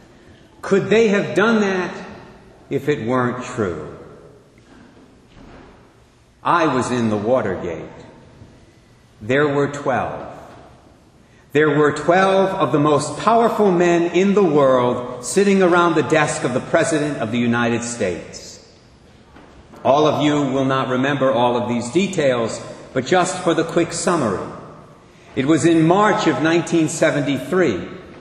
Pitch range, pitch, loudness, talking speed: 125-175 Hz, 150 Hz, -18 LUFS, 130 wpm